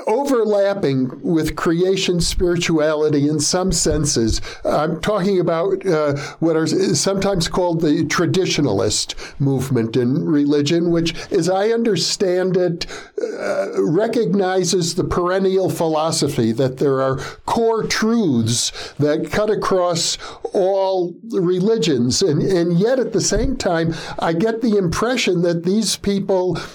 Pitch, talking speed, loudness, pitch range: 175 Hz, 120 wpm, -18 LUFS, 155-195 Hz